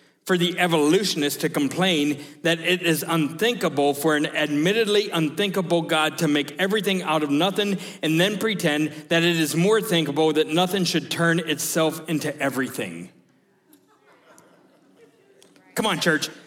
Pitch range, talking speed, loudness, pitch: 150-185 Hz, 140 wpm, -22 LUFS, 165 Hz